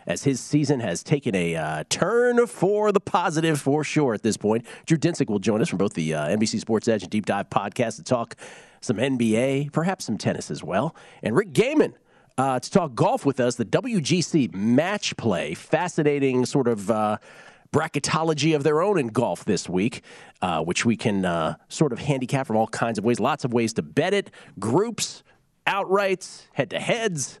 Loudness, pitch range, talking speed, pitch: -24 LUFS, 115-160 Hz, 195 wpm, 140 Hz